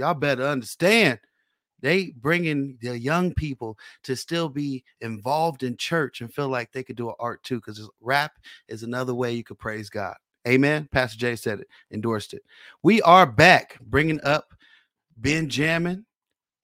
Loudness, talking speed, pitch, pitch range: -23 LUFS, 160 wpm, 130 Hz, 120-150 Hz